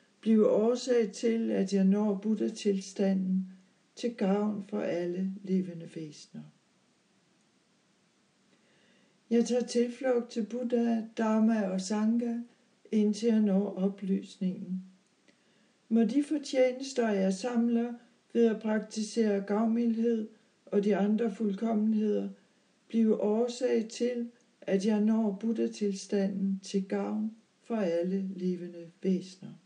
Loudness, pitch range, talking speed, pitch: -30 LUFS, 195-230 Hz, 105 wpm, 215 Hz